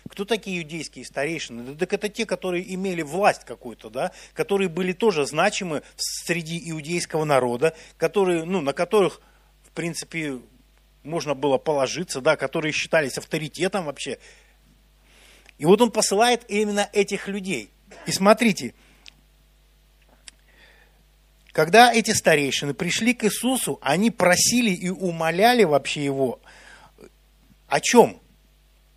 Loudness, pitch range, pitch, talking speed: -22 LUFS, 150-205 Hz, 175 Hz, 120 wpm